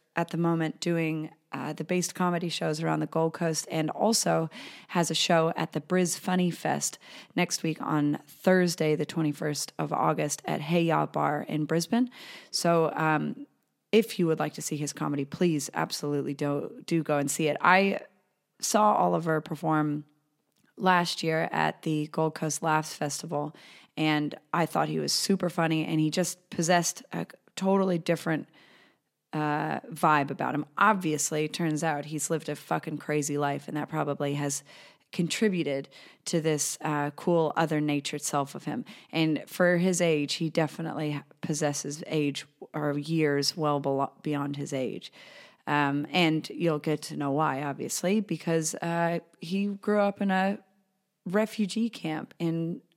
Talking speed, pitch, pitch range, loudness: 160 wpm, 160 Hz, 150-175 Hz, -28 LUFS